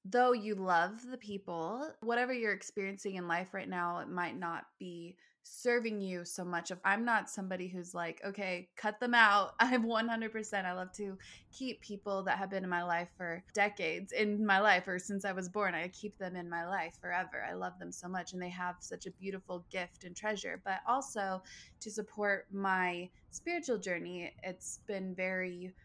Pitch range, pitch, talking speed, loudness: 180-210 Hz, 190 Hz, 195 wpm, -36 LUFS